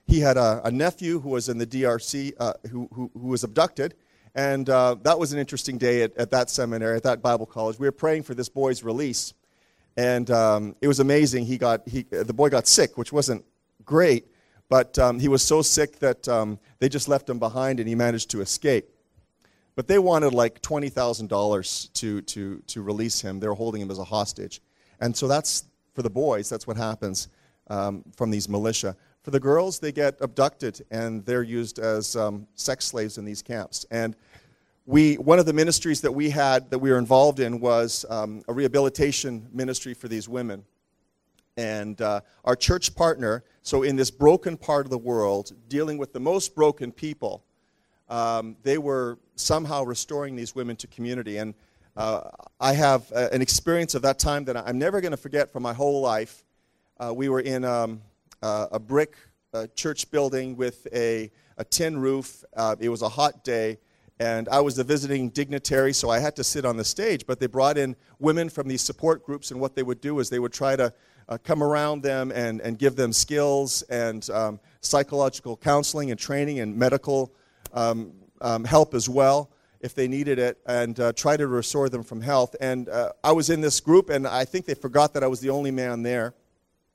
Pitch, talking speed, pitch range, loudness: 125 Hz, 200 wpm, 115-140 Hz, -24 LUFS